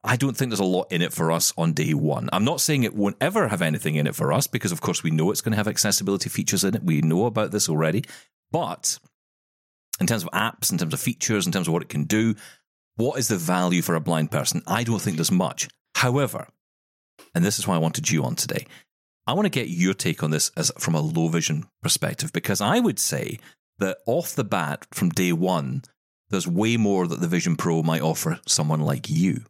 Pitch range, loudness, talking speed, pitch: 80-105 Hz, -23 LUFS, 240 wpm, 90 Hz